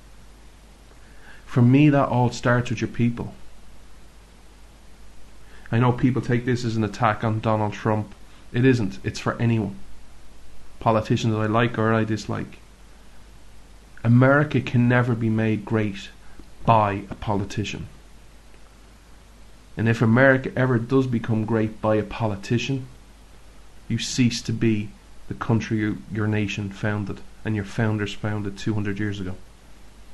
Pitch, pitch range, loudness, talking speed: 110 Hz, 105-120 Hz, -23 LUFS, 135 wpm